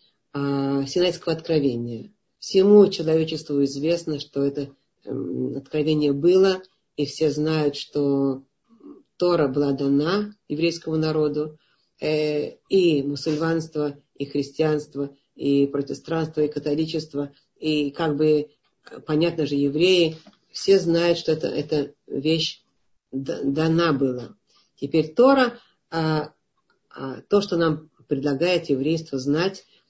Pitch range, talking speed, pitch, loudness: 140-165 Hz, 95 wpm, 155 Hz, -23 LUFS